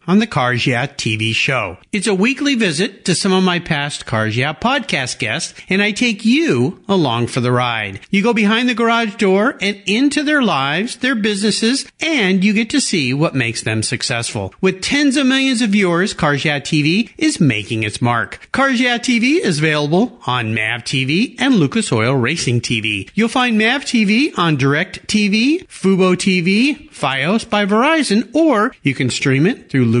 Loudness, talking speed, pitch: -15 LUFS, 185 wpm, 190 Hz